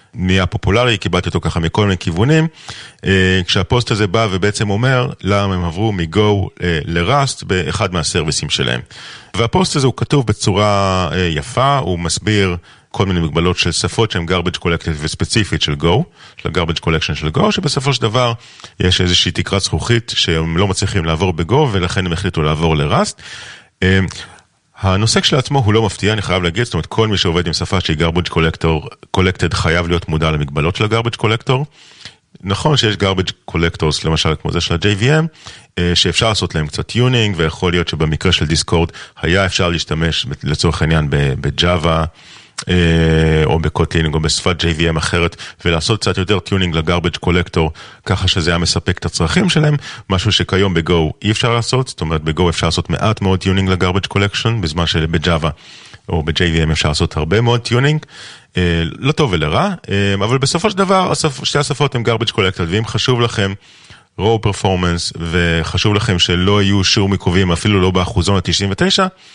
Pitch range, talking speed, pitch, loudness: 85-115 Hz, 160 wpm, 95 Hz, -15 LUFS